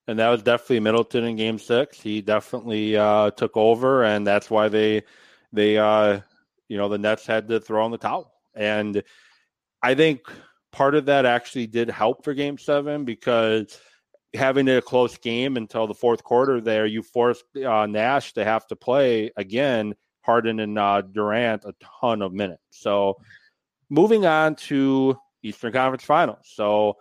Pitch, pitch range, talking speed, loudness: 115 Hz, 105-125 Hz, 170 wpm, -22 LUFS